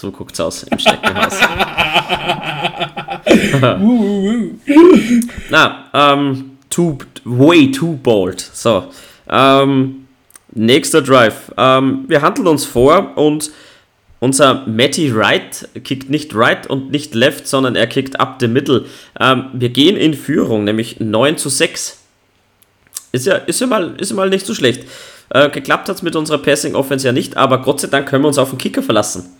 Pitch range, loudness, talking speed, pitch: 125-160 Hz, -13 LUFS, 155 wpm, 135 Hz